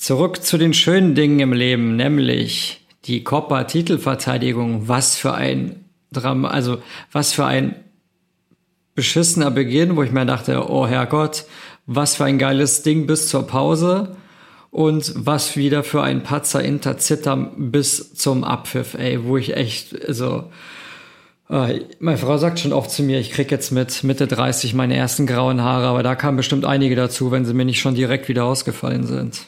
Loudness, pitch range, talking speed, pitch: -18 LUFS, 125-150 Hz, 165 wpm, 135 Hz